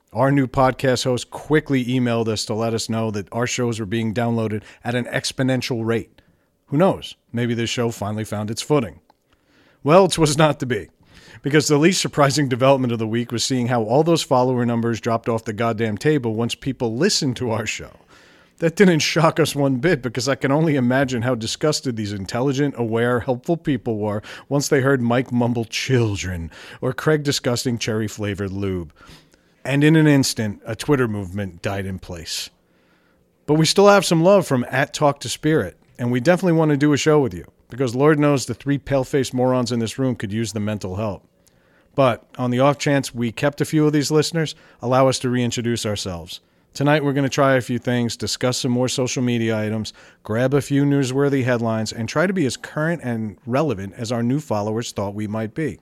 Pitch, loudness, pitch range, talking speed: 125 Hz, -20 LUFS, 115-140 Hz, 205 wpm